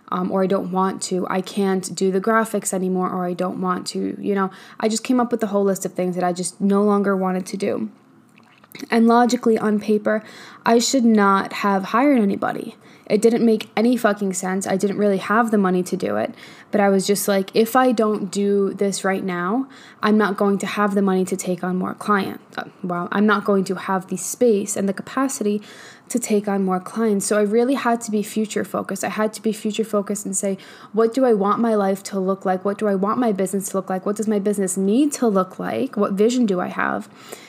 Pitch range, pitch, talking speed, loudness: 190-220 Hz, 205 Hz, 240 wpm, -20 LUFS